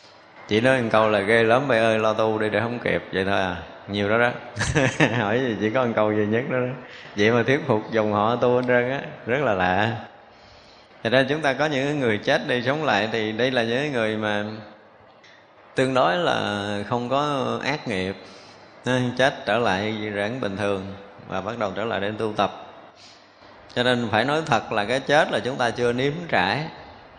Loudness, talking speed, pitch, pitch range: -22 LUFS, 215 wpm, 115 Hz, 105-125 Hz